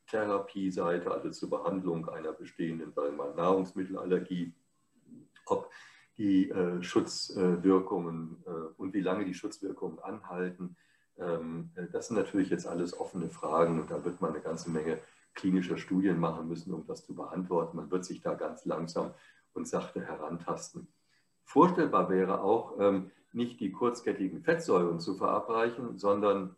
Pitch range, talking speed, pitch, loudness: 85-100 Hz, 130 wpm, 95 Hz, -33 LUFS